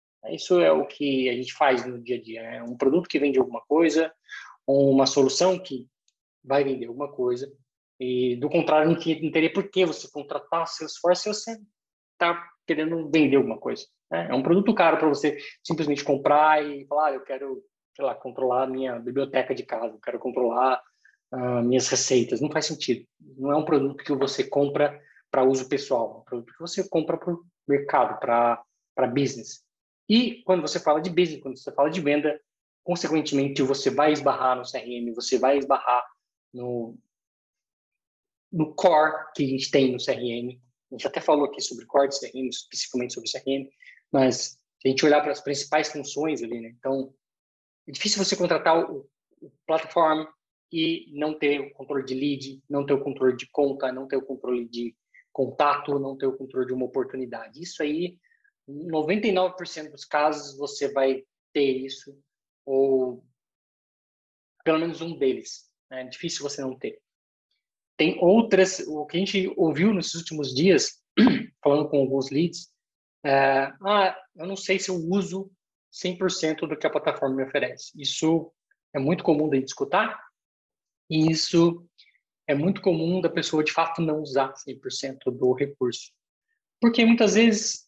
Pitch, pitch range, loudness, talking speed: 145 Hz, 135-165 Hz, -25 LUFS, 175 wpm